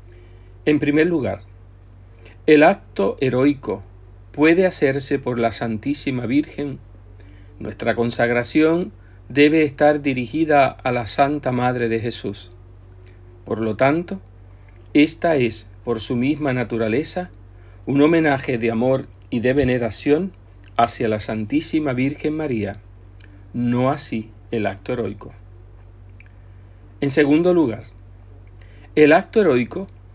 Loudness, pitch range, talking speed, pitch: -20 LUFS, 95-140 Hz, 110 wpm, 115 Hz